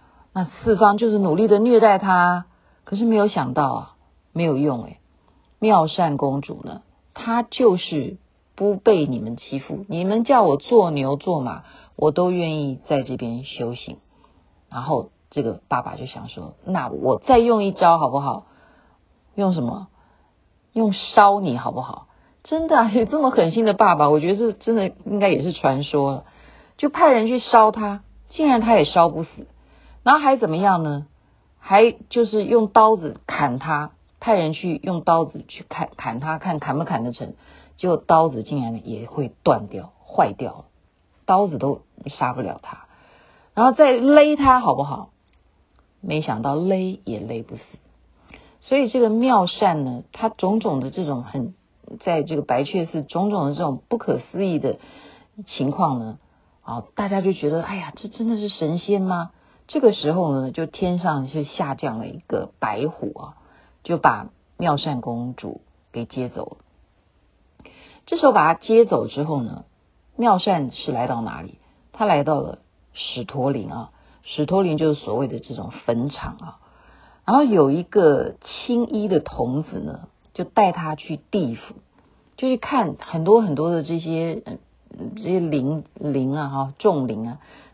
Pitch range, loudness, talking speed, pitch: 140-215 Hz, -20 LUFS, 230 characters per minute, 170 Hz